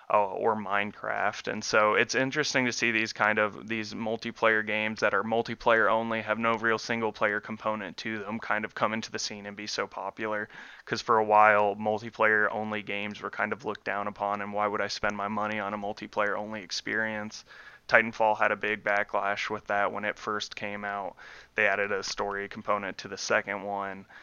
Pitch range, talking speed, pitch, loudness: 100-110 Hz, 205 wpm, 105 Hz, -28 LUFS